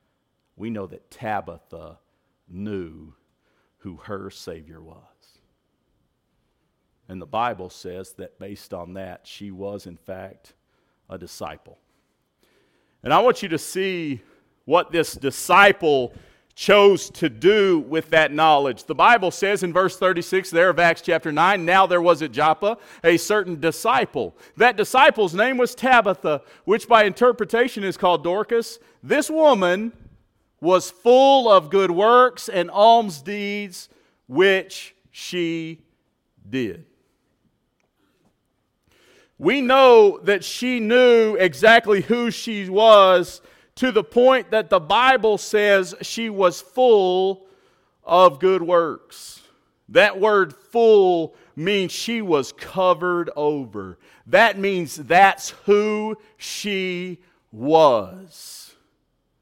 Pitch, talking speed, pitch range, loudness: 190 Hz, 120 wpm, 165-220 Hz, -18 LUFS